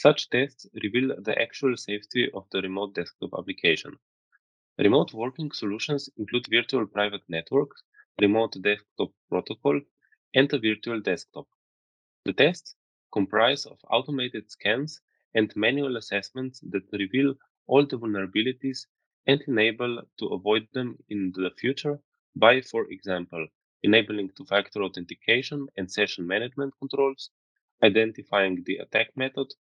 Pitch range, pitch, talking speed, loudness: 100-135 Hz, 115 Hz, 125 wpm, -26 LUFS